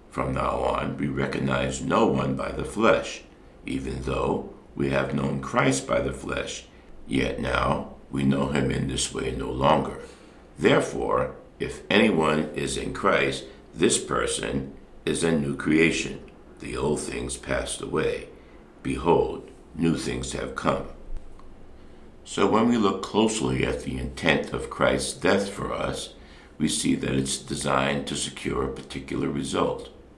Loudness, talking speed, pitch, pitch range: -26 LUFS, 145 wpm, 70 Hz, 65-70 Hz